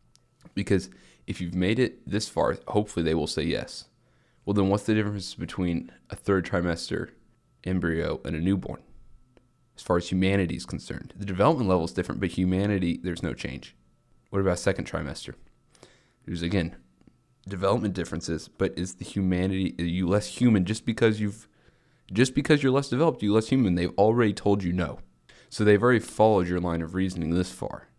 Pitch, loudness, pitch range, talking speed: 95 Hz, -26 LUFS, 85-105 Hz, 180 wpm